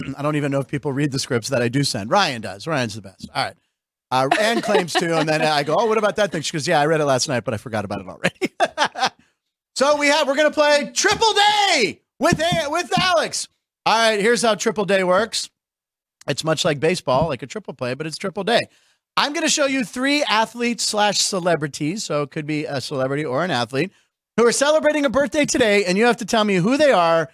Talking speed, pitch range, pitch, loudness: 240 wpm, 145-240 Hz, 185 Hz, -19 LUFS